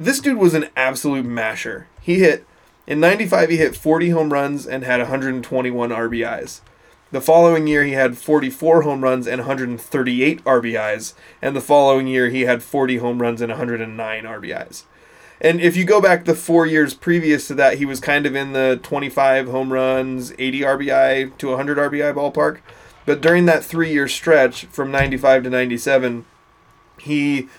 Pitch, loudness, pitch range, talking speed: 135 Hz, -17 LUFS, 130-155 Hz, 170 wpm